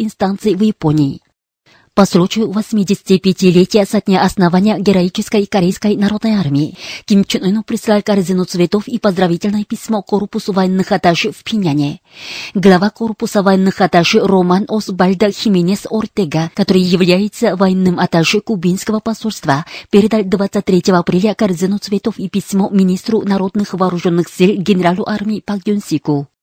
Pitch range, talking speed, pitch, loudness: 185-210 Hz, 125 wpm, 195 Hz, -14 LUFS